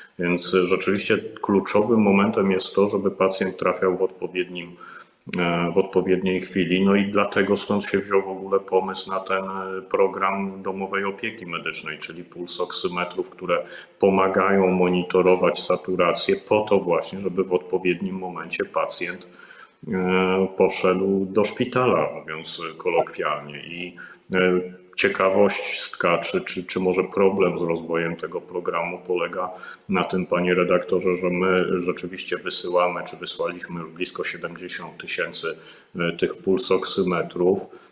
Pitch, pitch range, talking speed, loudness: 95 Hz, 90-95 Hz, 120 wpm, -23 LUFS